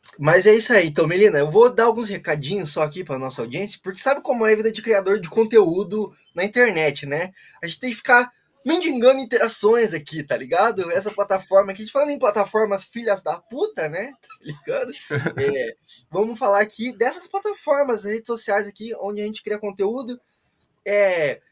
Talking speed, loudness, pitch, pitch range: 190 wpm, -20 LUFS, 215 Hz, 195-250 Hz